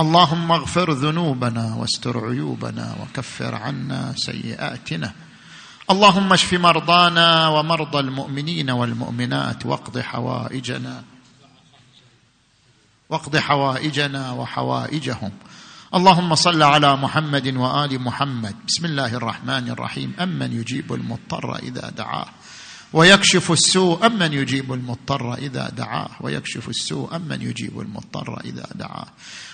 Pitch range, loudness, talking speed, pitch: 120-165 Hz, -19 LUFS, 100 wpm, 140 Hz